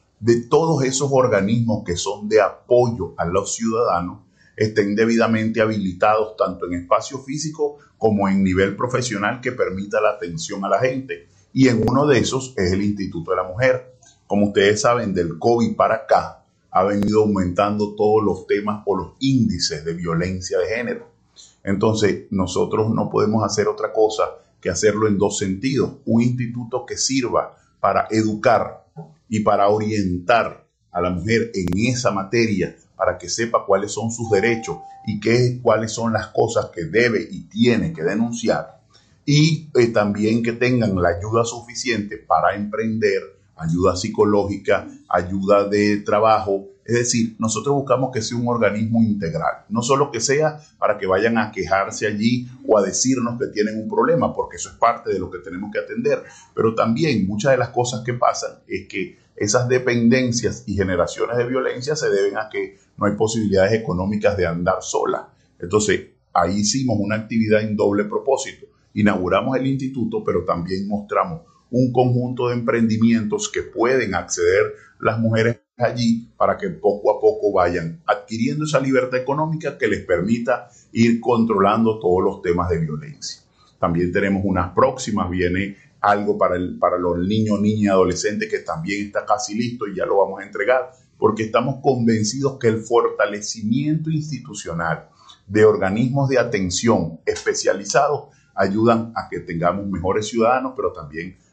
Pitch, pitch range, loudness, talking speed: 110 Hz, 100-125 Hz, -20 LUFS, 160 wpm